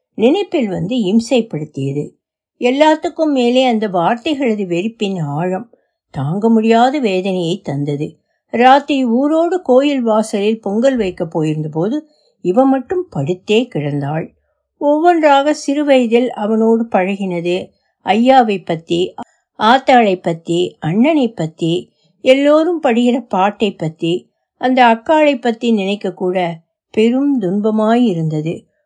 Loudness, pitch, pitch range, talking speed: -15 LUFS, 225 Hz, 180-260 Hz, 75 wpm